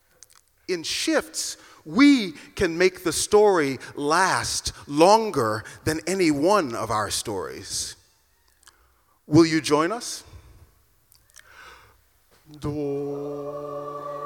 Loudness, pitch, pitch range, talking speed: -23 LUFS, 145 Hz, 120-175 Hz, 85 wpm